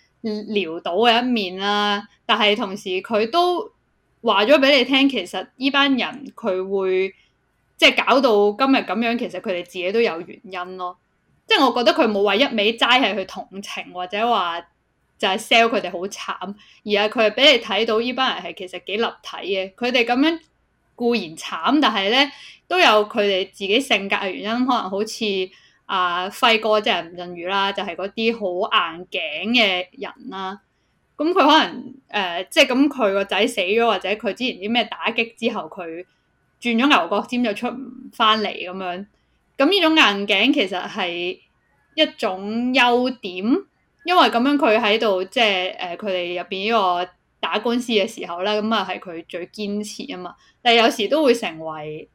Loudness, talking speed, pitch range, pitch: -19 LUFS, 255 characters per minute, 190-245 Hz, 215 Hz